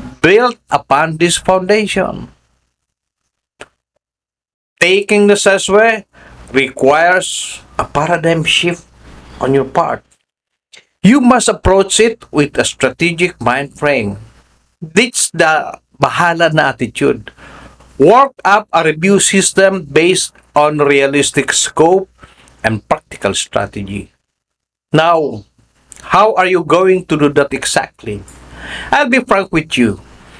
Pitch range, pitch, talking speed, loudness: 135-195 Hz, 165 Hz, 105 wpm, -12 LUFS